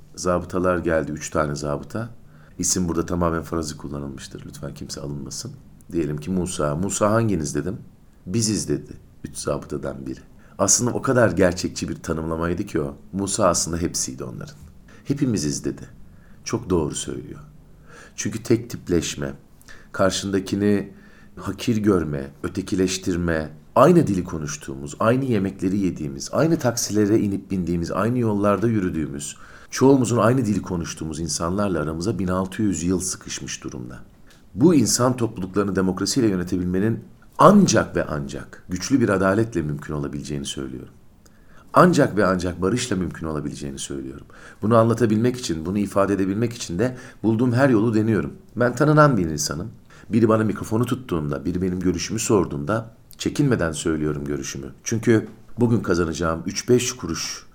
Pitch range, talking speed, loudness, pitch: 80-110 Hz, 130 wpm, -22 LUFS, 95 Hz